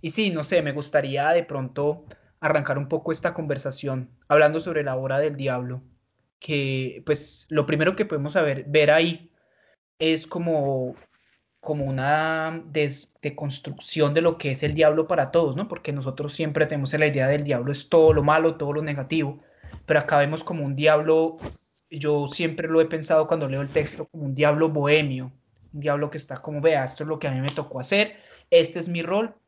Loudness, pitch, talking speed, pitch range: -23 LUFS, 150 Hz, 195 wpm, 140-160 Hz